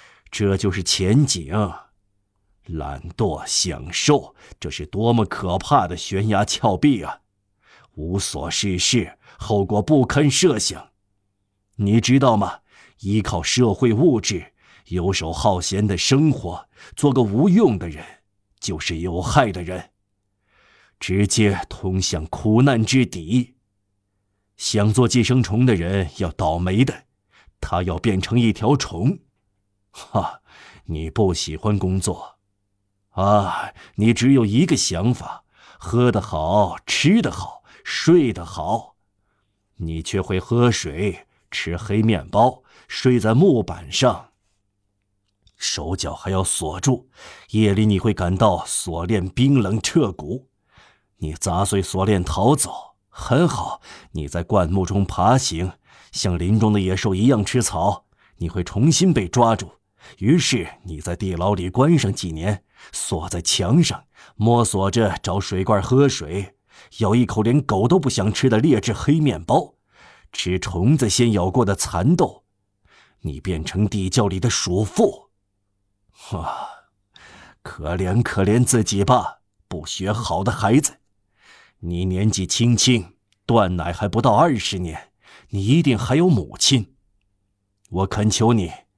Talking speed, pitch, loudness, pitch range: 180 characters per minute, 100 Hz, -20 LUFS, 95-115 Hz